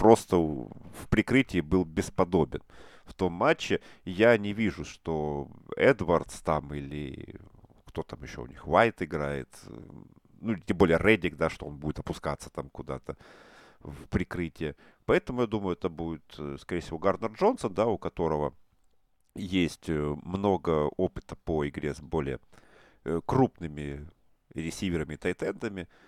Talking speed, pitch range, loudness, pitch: 135 wpm, 75-95 Hz, -29 LUFS, 85 Hz